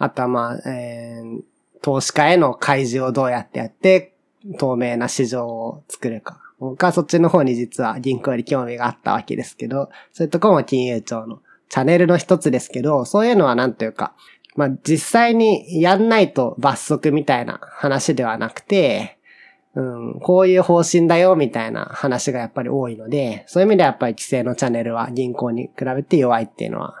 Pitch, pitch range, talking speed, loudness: 135 Hz, 120-170 Hz, 385 characters per minute, -18 LUFS